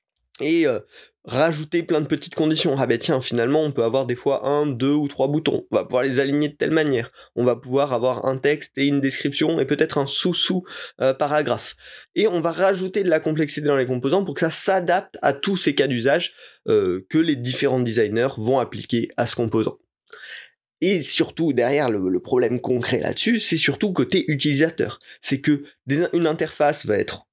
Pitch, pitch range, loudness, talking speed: 145 Hz, 130-165 Hz, -21 LUFS, 200 wpm